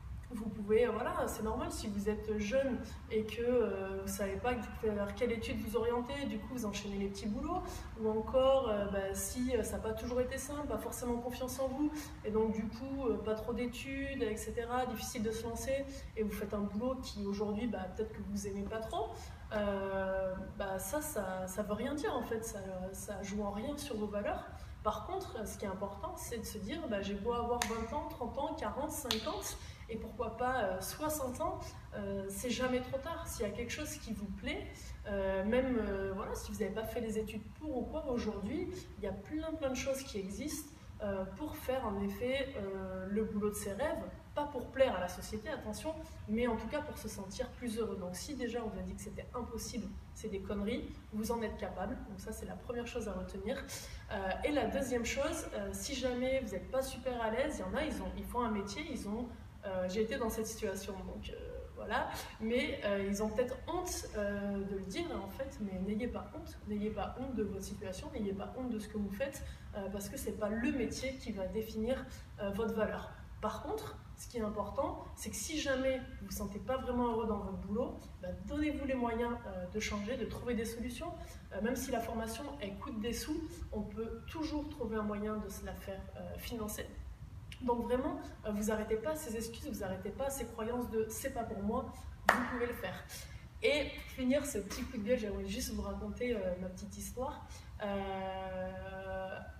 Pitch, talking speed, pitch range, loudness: 225 Hz, 220 wpm, 205-255 Hz, -39 LUFS